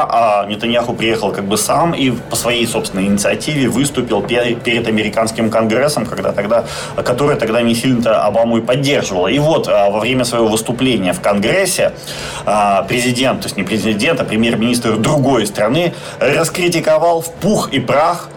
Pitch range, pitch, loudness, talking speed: 110-125 Hz, 115 Hz, -14 LUFS, 150 wpm